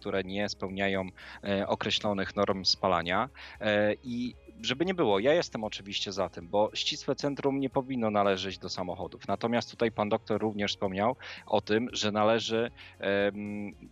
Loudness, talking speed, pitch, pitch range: -30 LUFS, 160 wpm, 105 Hz, 100-115 Hz